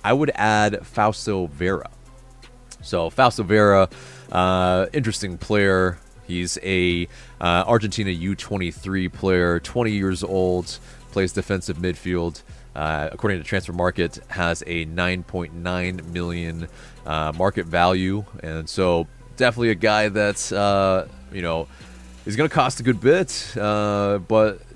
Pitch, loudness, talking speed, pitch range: 95 Hz, -22 LUFS, 125 wpm, 85-105 Hz